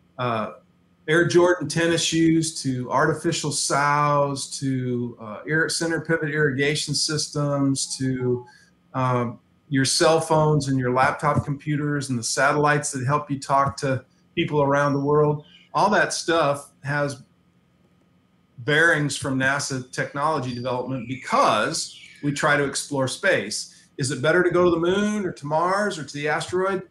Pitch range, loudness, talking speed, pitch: 135-160 Hz, -22 LUFS, 145 wpm, 145 Hz